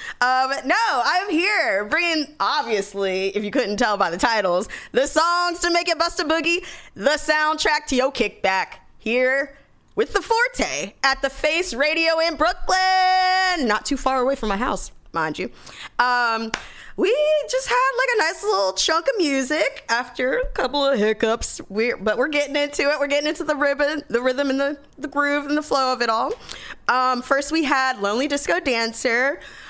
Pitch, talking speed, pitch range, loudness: 285 Hz, 185 wpm, 250-325 Hz, -21 LUFS